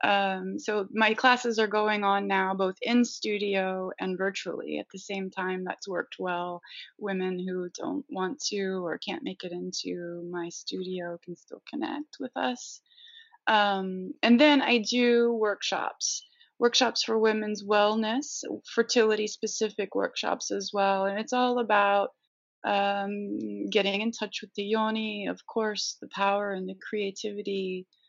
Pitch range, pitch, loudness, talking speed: 190-225 Hz, 205 Hz, -28 LUFS, 150 wpm